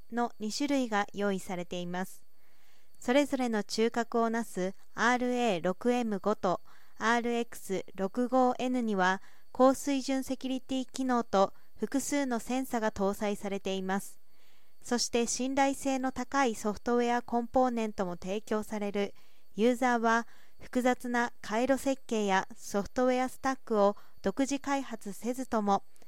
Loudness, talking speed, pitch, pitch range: -31 LUFS, 270 characters per minute, 235 Hz, 205-255 Hz